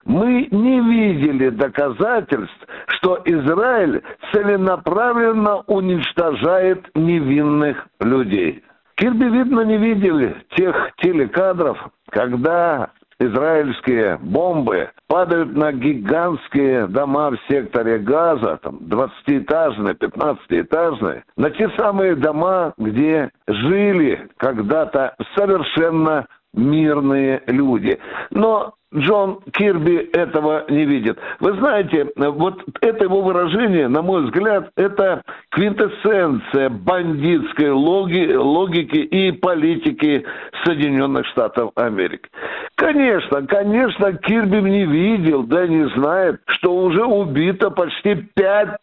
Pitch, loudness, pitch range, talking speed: 180 Hz, -17 LUFS, 150-210 Hz, 95 wpm